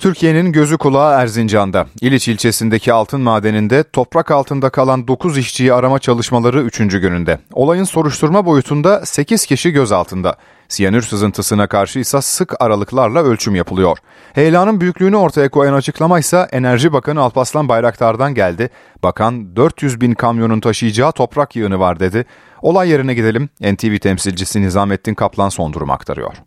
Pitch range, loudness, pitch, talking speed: 105-145 Hz, -14 LUFS, 125 Hz, 140 wpm